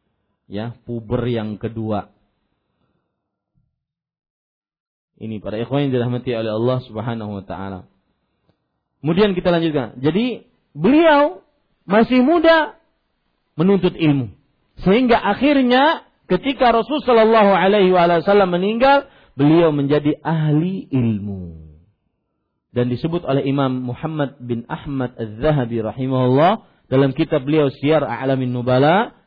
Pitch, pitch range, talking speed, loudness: 140 Hz, 120-190 Hz, 105 wpm, -17 LUFS